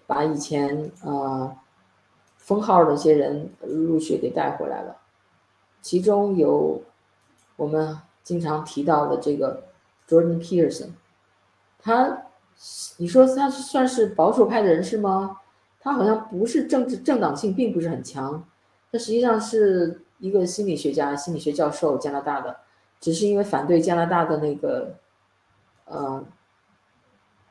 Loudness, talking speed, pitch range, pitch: -22 LUFS, 225 characters per minute, 135-200 Hz, 160 Hz